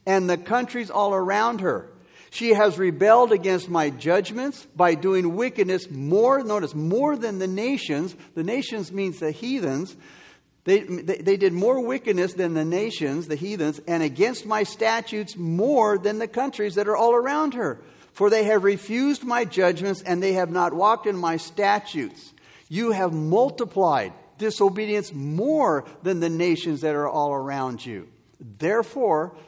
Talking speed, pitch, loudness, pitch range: 160 wpm, 195 Hz, -23 LUFS, 170-225 Hz